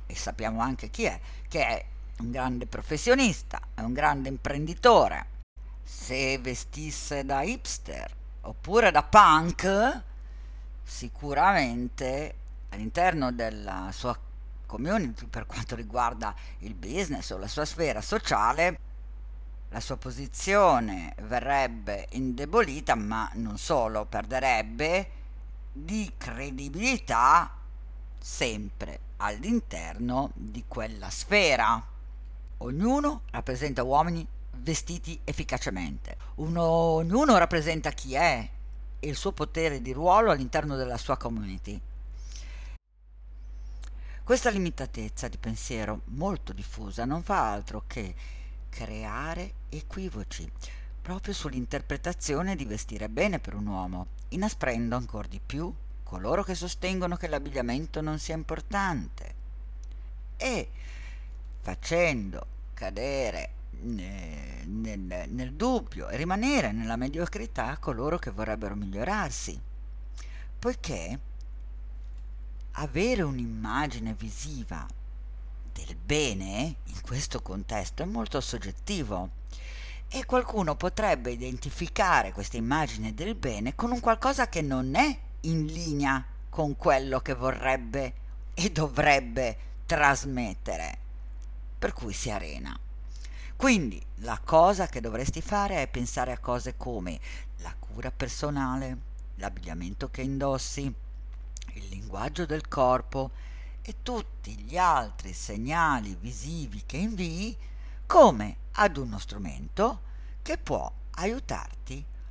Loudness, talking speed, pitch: -29 LUFS, 105 wpm, 120 Hz